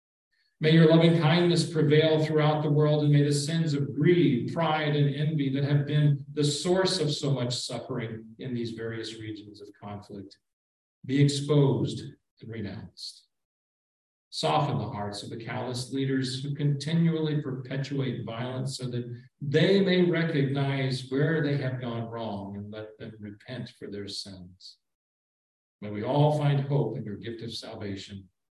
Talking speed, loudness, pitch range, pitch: 155 wpm, -27 LUFS, 110-150 Hz, 135 Hz